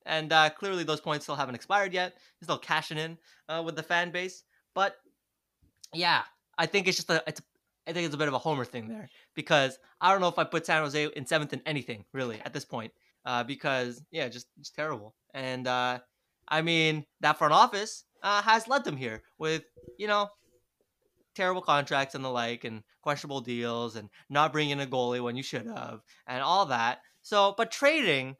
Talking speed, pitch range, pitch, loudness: 205 wpm, 130-170 Hz, 155 Hz, -29 LUFS